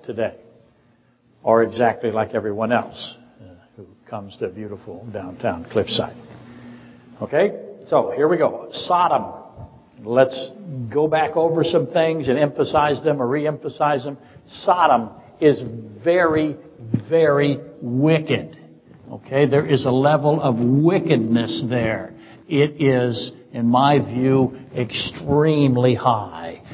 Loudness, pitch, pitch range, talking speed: -19 LUFS, 130 Hz, 120-150 Hz, 115 wpm